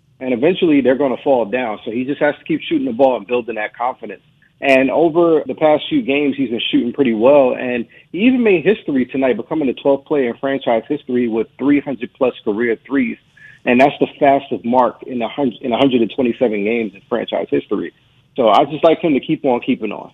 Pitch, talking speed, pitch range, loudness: 135 Hz, 215 wpm, 120-150 Hz, -16 LUFS